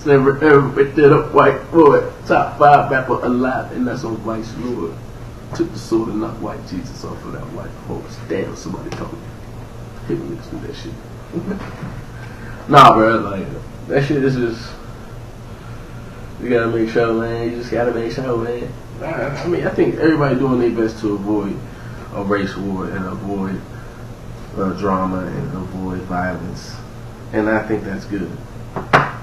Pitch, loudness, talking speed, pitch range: 115 Hz, -17 LUFS, 165 wpm, 110-125 Hz